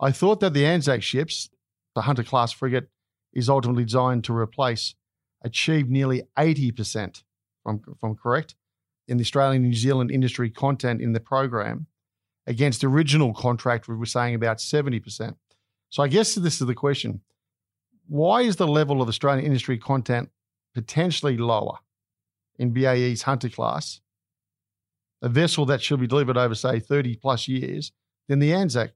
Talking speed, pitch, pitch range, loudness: 160 wpm, 125 Hz, 115-140 Hz, -23 LUFS